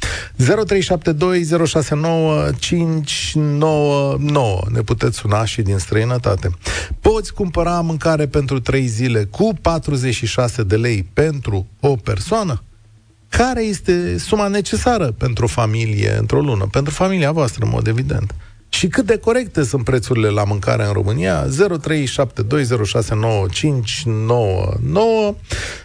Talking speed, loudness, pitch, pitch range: 100 wpm, -17 LUFS, 130 Hz, 110-165 Hz